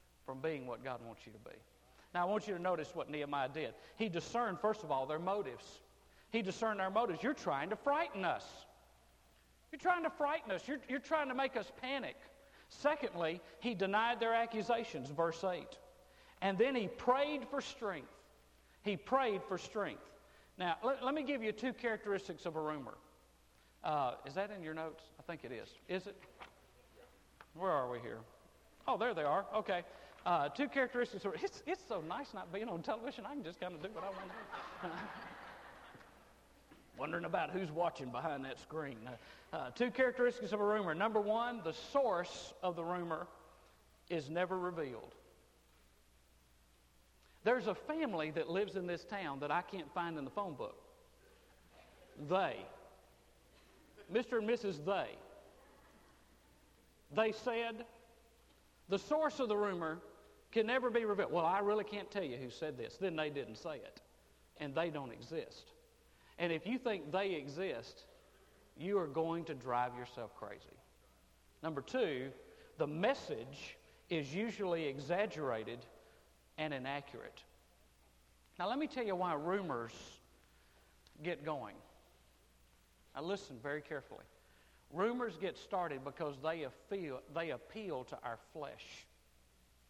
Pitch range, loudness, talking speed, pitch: 140-230 Hz, -40 LUFS, 160 wpm, 180 Hz